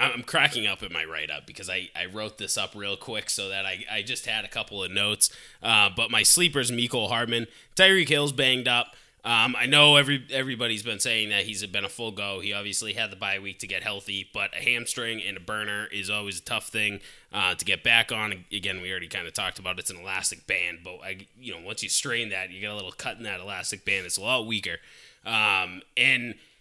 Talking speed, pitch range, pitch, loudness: 240 wpm, 100-120 Hz, 105 Hz, -24 LUFS